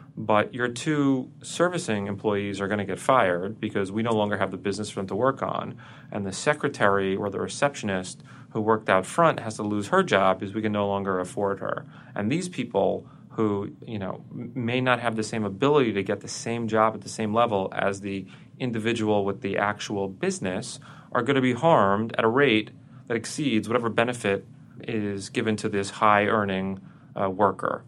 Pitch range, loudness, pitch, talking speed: 100-125 Hz, -25 LUFS, 110 Hz, 200 wpm